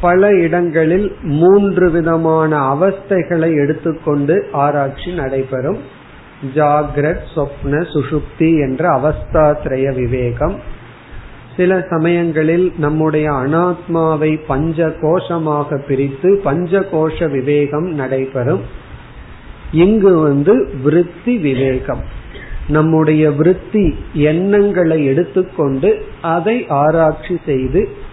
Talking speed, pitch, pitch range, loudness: 70 wpm, 155 Hz, 140-175 Hz, -14 LUFS